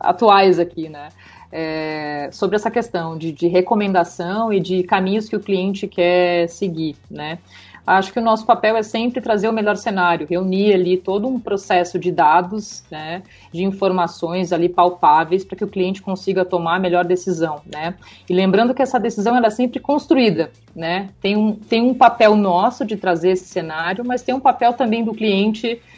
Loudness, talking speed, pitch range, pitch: -18 LUFS, 180 wpm, 175-220 Hz, 190 Hz